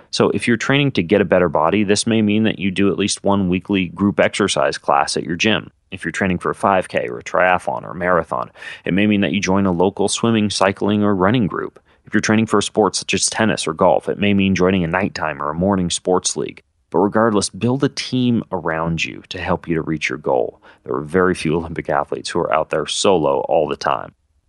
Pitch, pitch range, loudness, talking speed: 100 Hz, 90-105 Hz, -18 LUFS, 245 wpm